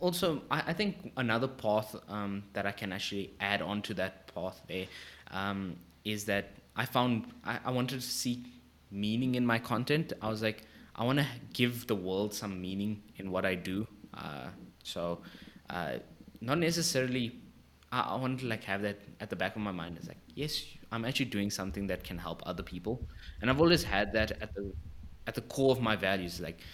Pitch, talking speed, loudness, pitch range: 105 Hz, 200 wpm, -34 LUFS, 95-125 Hz